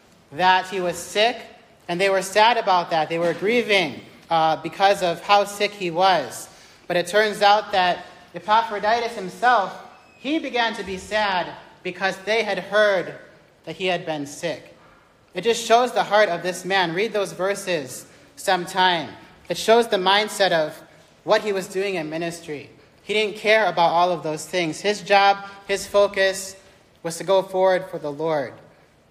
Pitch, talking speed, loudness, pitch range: 190 Hz, 170 wpm, -21 LUFS, 175-205 Hz